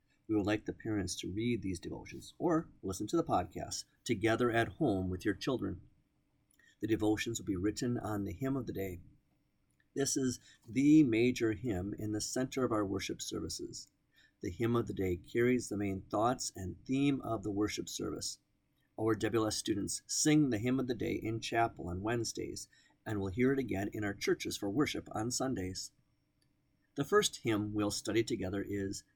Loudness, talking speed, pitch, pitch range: -35 LUFS, 185 wpm, 110 Hz, 100-125 Hz